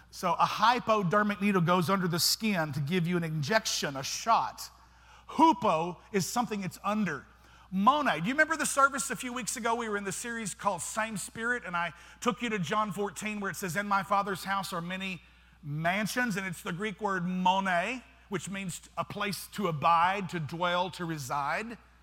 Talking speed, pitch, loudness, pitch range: 195 wpm, 195 Hz, -30 LUFS, 175-220 Hz